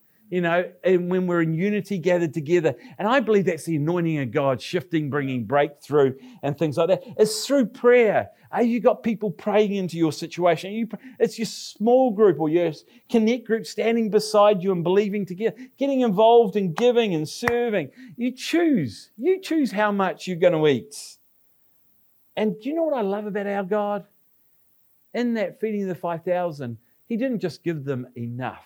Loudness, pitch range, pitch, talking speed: -23 LUFS, 170-230 Hz, 200 Hz, 180 wpm